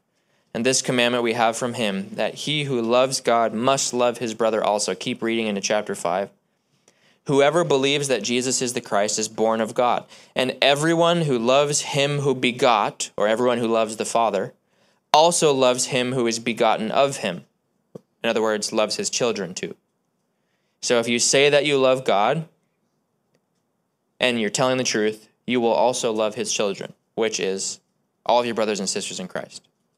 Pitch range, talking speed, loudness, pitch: 110-140 Hz, 180 wpm, -21 LUFS, 125 Hz